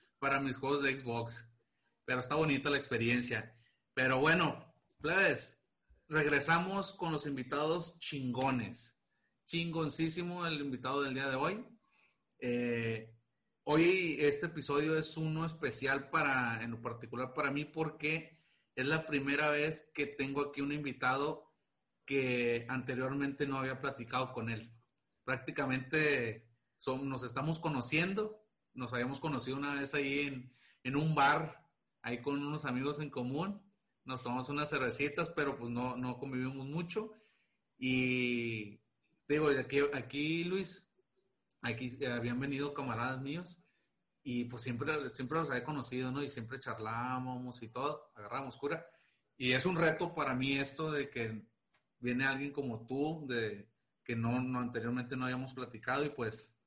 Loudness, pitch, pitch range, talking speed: -35 LUFS, 135 Hz, 125-150 Hz, 140 wpm